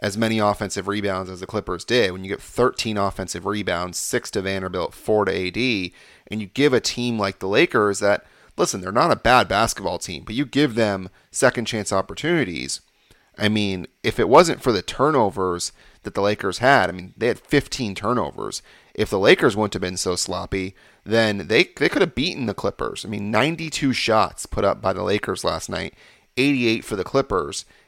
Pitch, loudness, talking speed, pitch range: 105 Hz, -21 LUFS, 200 wpm, 95-115 Hz